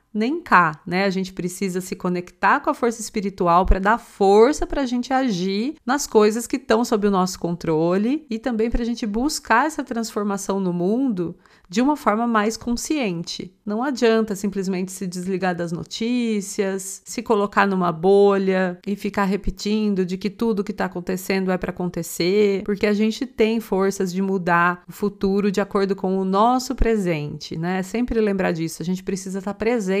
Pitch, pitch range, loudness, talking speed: 205 Hz, 185-230 Hz, -21 LUFS, 180 wpm